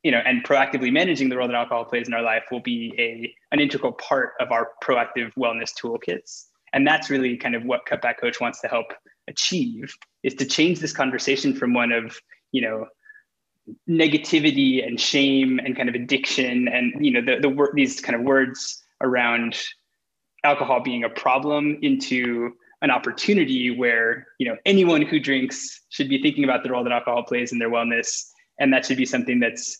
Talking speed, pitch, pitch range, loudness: 190 wpm, 130 Hz, 120-155 Hz, -22 LUFS